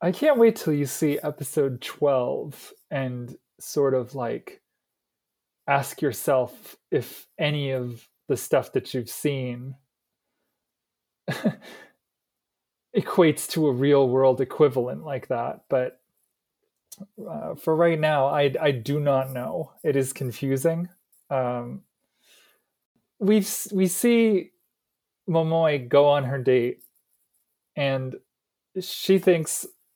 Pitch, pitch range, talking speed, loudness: 145 Hz, 130-180 Hz, 110 wpm, -24 LUFS